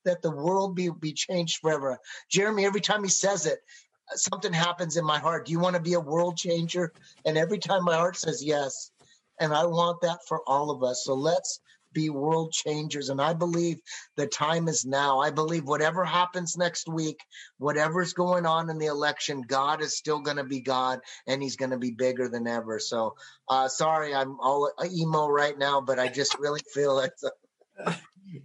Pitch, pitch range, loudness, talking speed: 155 Hz, 140-175 Hz, -27 LUFS, 200 wpm